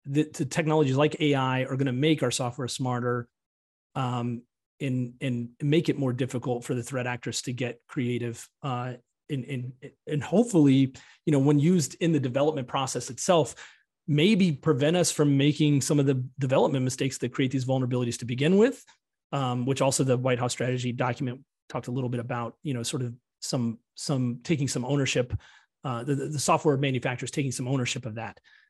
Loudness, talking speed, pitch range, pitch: -27 LUFS, 190 wpm, 125-145 Hz, 130 Hz